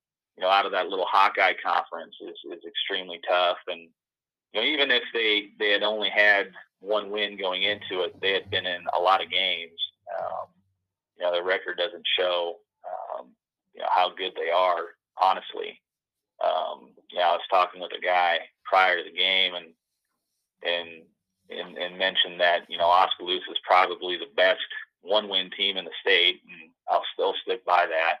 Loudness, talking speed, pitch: -24 LUFS, 185 wpm, 100 Hz